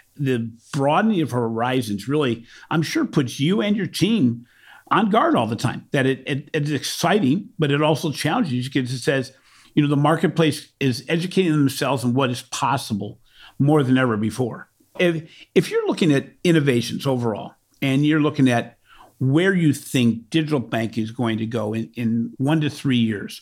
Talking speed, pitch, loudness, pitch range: 180 wpm, 140 Hz, -21 LUFS, 120-155 Hz